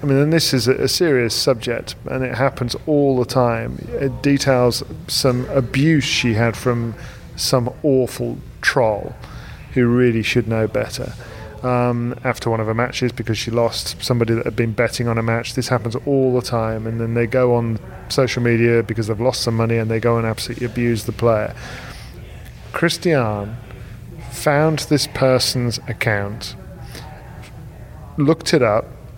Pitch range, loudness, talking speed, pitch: 115-130 Hz, -19 LUFS, 160 wpm, 120 Hz